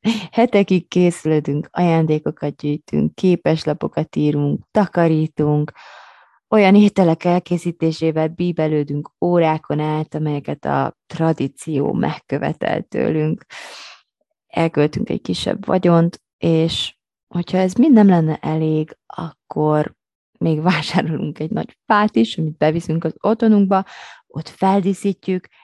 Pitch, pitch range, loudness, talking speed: 165 Hz, 155-185 Hz, -18 LUFS, 100 wpm